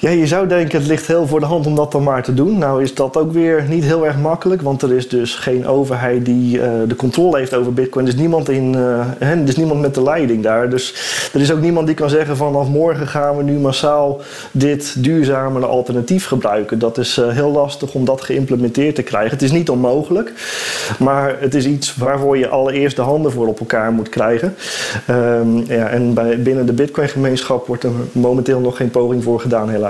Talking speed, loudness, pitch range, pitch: 215 wpm, -15 LUFS, 125-150 Hz, 135 Hz